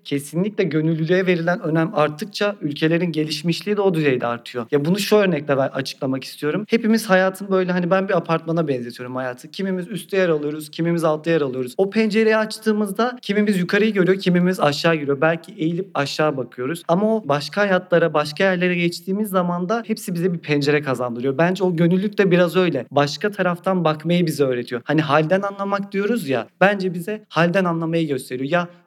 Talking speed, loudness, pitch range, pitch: 175 wpm, -20 LUFS, 150-195 Hz, 175 Hz